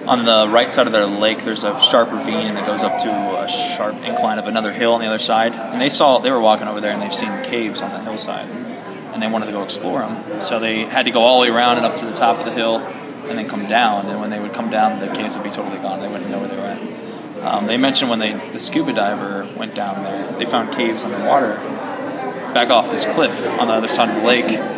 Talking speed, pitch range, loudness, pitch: 275 wpm, 110-115 Hz, -18 LUFS, 110 Hz